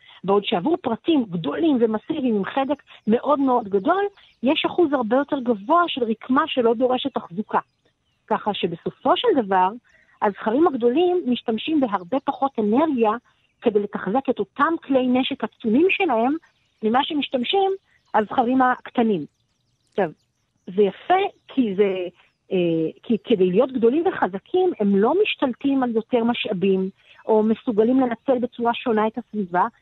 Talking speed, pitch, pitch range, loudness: 130 wpm, 245 Hz, 215-285 Hz, -22 LUFS